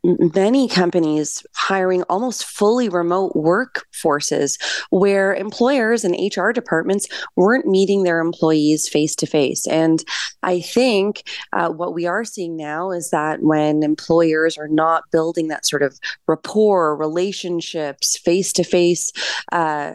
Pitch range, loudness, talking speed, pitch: 160-195 Hz, -18 LUFS, 130 wpm, 175 Hz